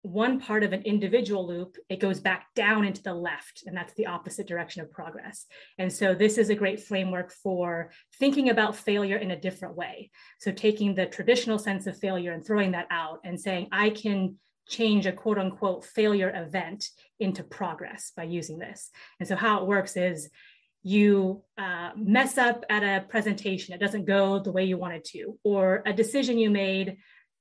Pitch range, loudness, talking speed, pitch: 185-210 Hz, -27 LUFS, 190 wpm, 195 Hz